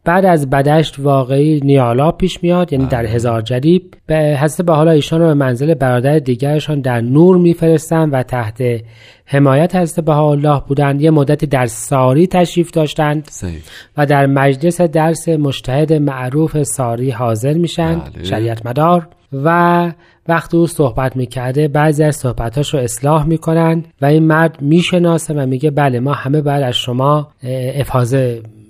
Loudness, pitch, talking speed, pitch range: -13 LUFS, 150 Hz, 150 wpm, 130-165 Hz